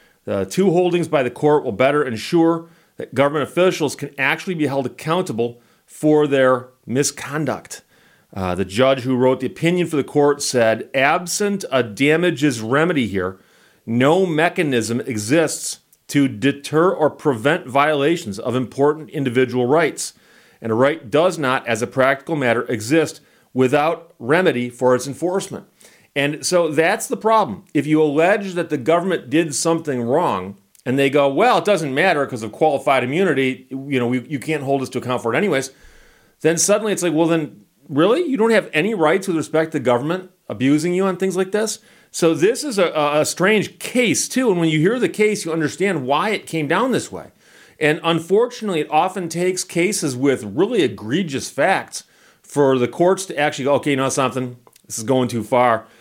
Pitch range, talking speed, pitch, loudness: 130-175 Hz, 180 wpm, 150 Hz, -19 LUFS